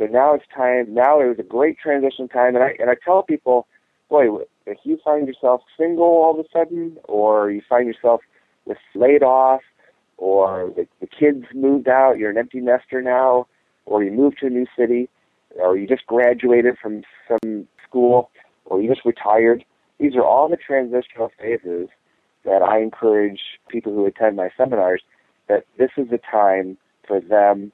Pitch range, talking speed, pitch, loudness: 110-135 Hz, 185 wpm, 125 Hz, -18 LUFS